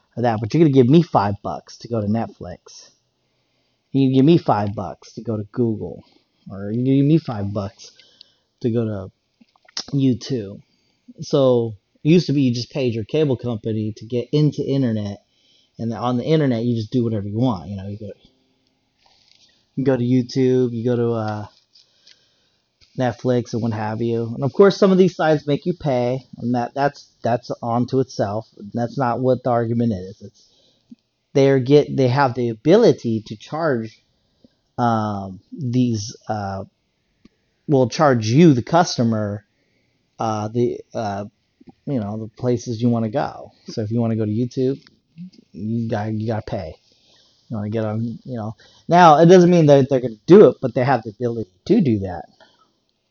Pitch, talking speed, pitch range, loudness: 120 Hz, 185 wpm, 110-135 Hz, -19 LUFS